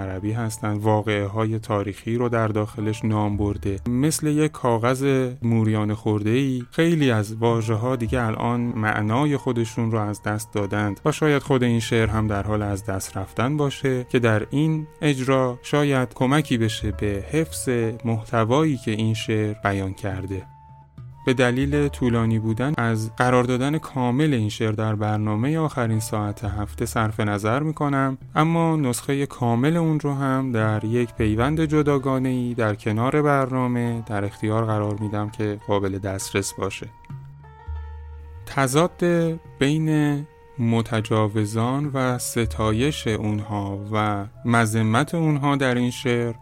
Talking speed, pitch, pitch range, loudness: 140 wpm, 115 Hz, 105-135 Hz, -23 LUFS